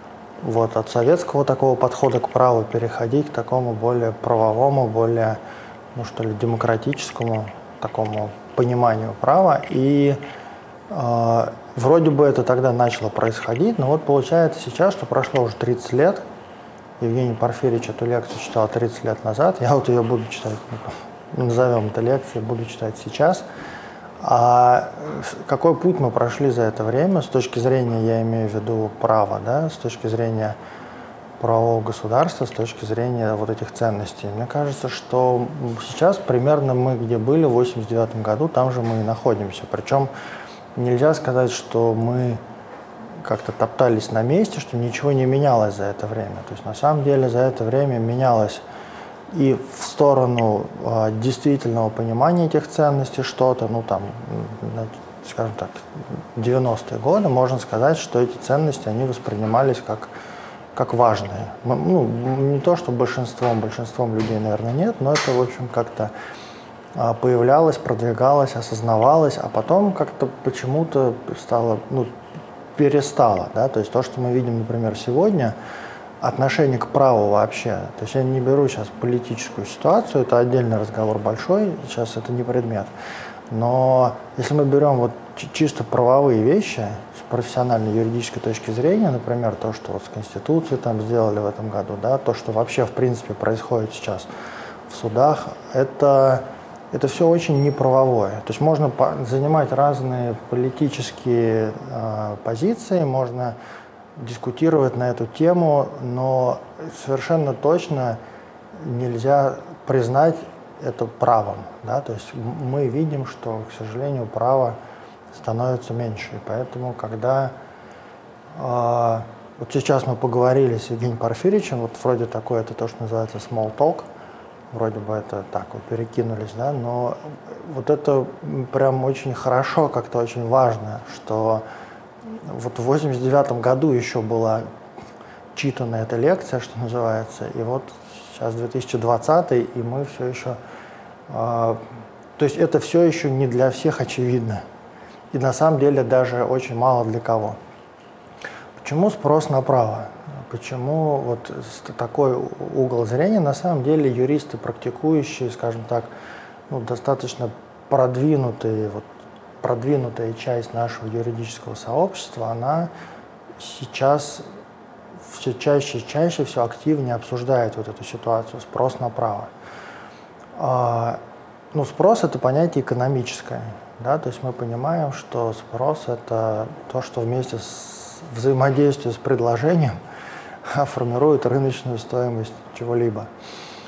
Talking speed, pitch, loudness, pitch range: 135 wpm, 125 Hz, -21 LUFS, 115-135 Hz